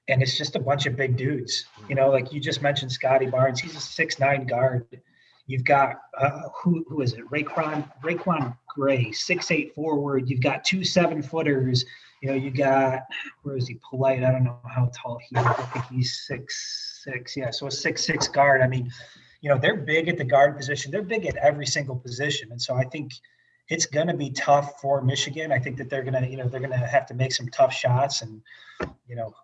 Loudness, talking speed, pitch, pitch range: -24 LUFS, 215 wpm, 135 Hz, 130-150 Hz